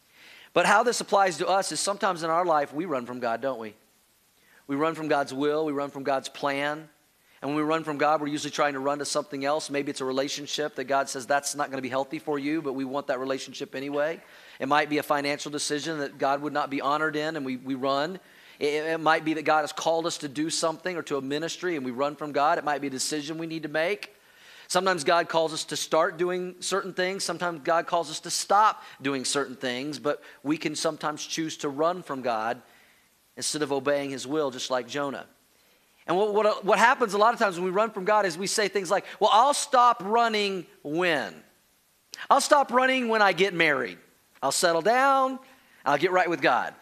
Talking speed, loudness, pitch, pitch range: 235 wpm, -26 LUFS, 155 Hz, 140-180 Hz